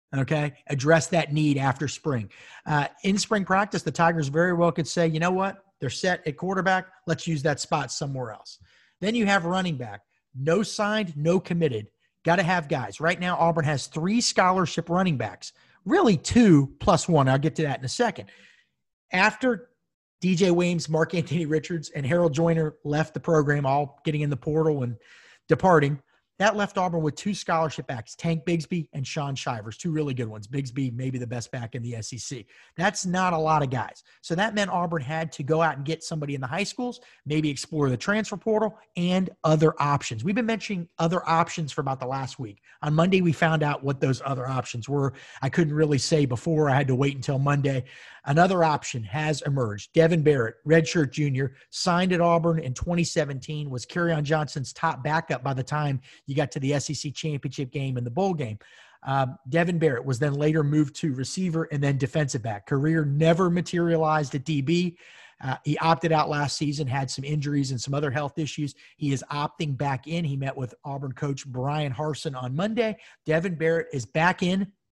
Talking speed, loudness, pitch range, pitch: 195 wpm, -25 LUFS, 140-170 Hz, 155 Hz